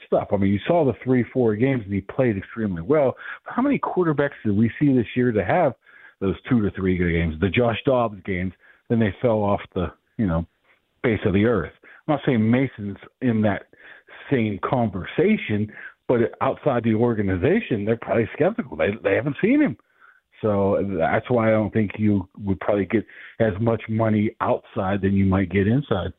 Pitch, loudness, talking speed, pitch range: 110 Hz, -22 LUFS, 190 wpm, 100-125 Hz